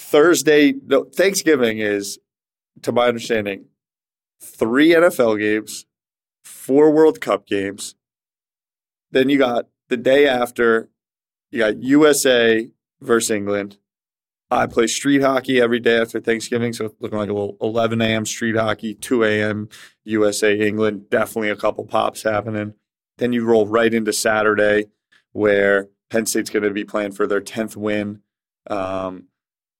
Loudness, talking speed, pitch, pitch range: -18 LUFS, 140 wpm, 110 Hz, 105-120 Hz